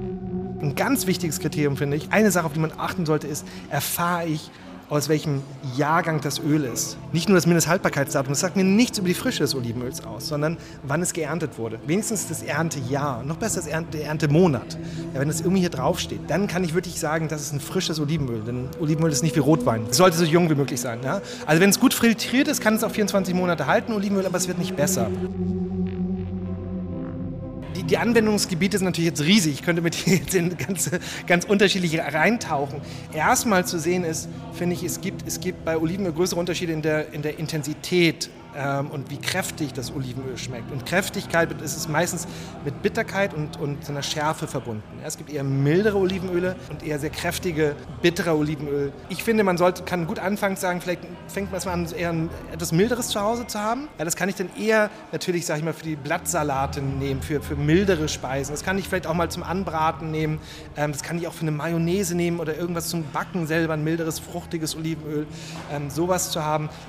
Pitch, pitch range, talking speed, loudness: 165 Hz, 150-180 Hz, 205 wpm, -24 LUFS